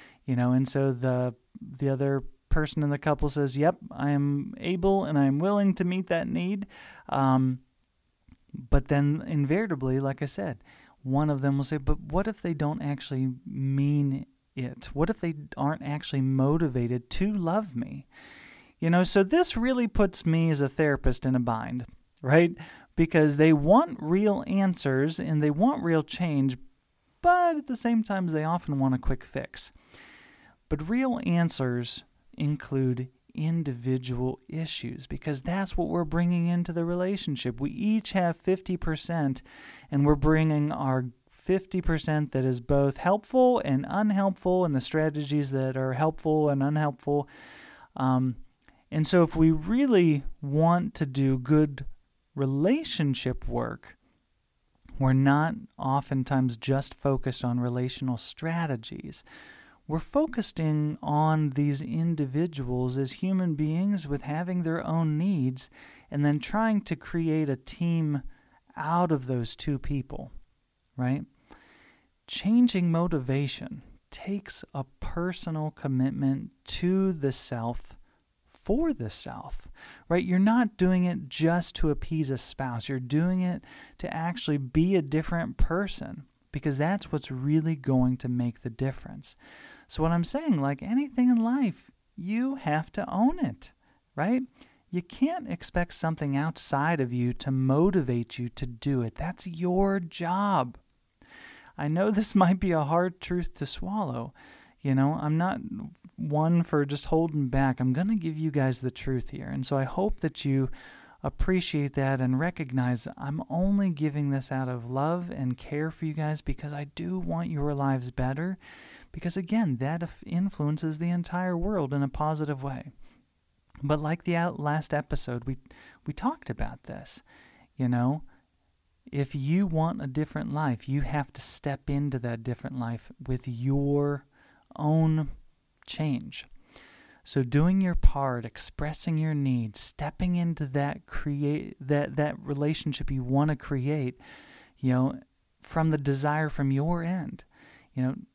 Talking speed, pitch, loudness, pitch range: 150 wpm, 150 Hz, -28 LUFS, 135-175 Hz